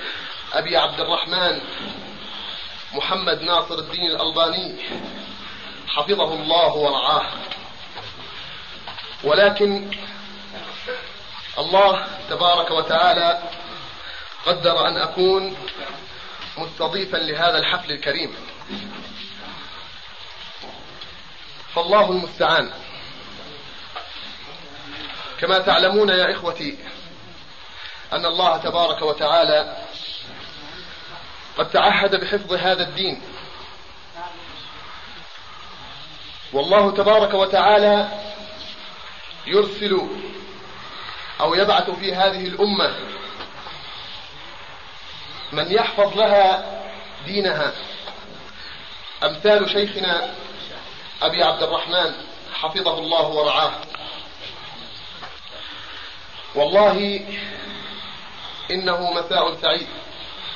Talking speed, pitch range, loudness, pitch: 60 wpm, 165-205 Hz, -19 LUFS, 185 Hz